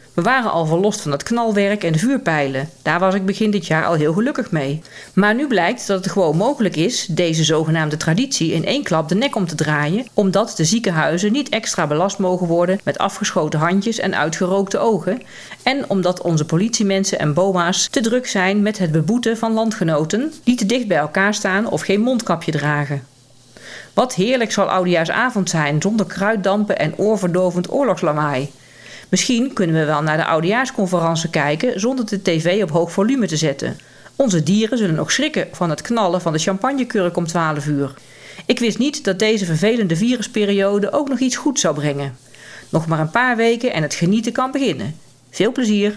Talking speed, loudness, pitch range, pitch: 185 wpm, -18 LUFS, 160-220 Hz, 190 Hz